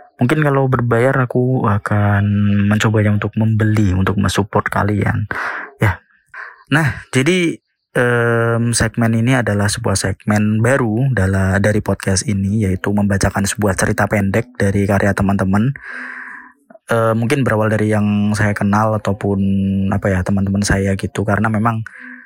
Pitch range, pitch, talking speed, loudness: 100-115 Hz, 105 Hz, 130 wpm, -16 LUFS